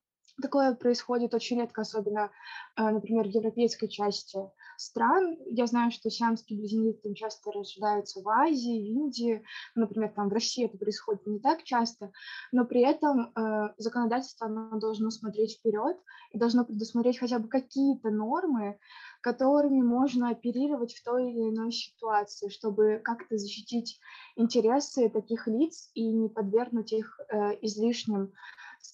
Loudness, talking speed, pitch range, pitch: -30 LUFS, 135 wpm, 215-245 Hz, 230 Hz